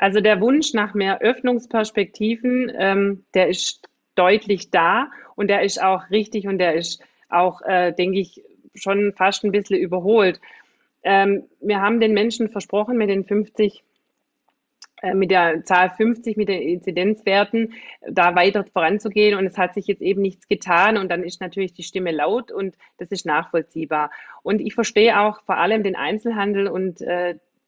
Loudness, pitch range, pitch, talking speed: -20 LUFS, 185-215 Hz, 200 Hz, 165 wpm